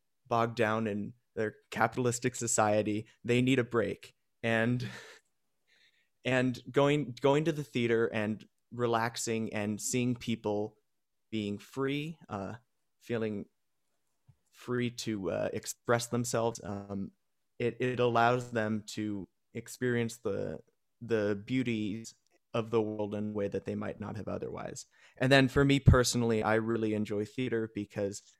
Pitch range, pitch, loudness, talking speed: 105-125 Hz, 115 Hz, -32 LUFS, 135 wpm